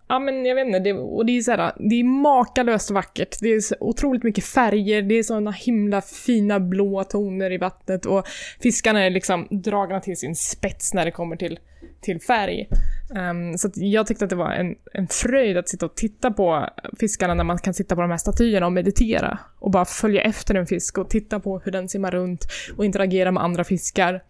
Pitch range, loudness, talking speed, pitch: 185-220 Hz, -22 LUFS, 215 wpm, 195 Hz